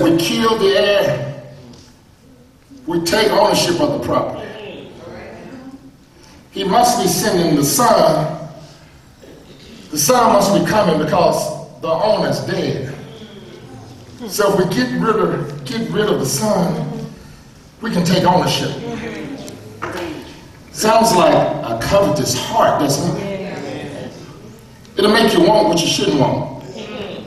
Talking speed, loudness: 120 wpm, -16 LUFS